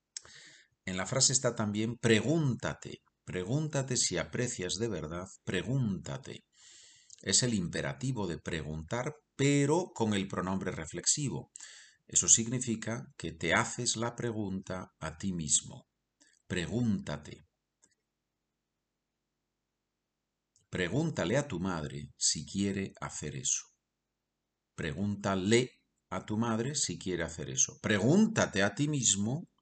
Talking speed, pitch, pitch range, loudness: 105 wpm, 100 Hz, 85-120 Hz, -31 LUFS